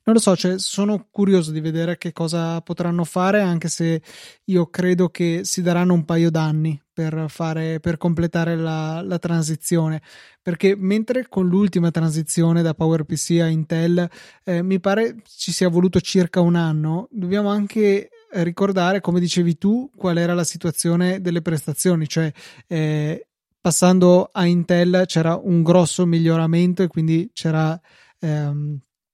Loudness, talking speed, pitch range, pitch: -20 LUFS, 150 wpm, 165-185 Hz, 175 Hz